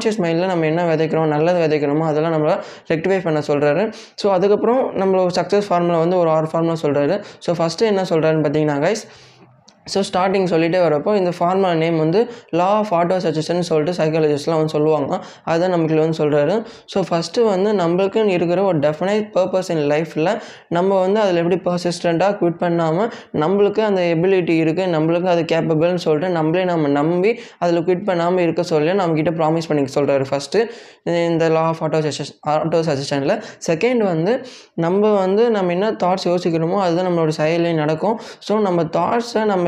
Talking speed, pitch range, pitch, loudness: 165 wpm, 160-190 Hz, 175 Hz, -18 LUFS